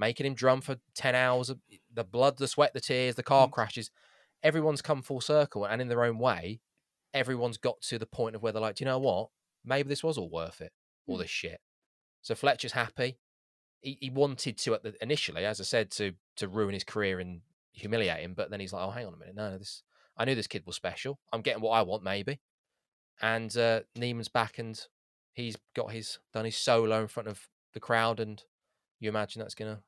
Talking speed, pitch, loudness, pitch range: 225 wpm, 115 Hz, -31 LUFS, 110-130 Hz